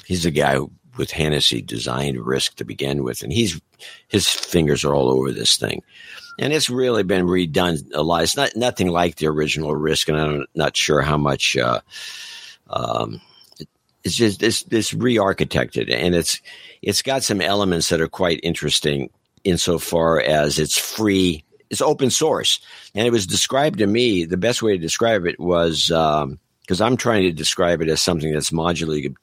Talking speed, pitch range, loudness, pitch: 180 wpm, 75-100 Hz, -19 LUFS, 85 Hz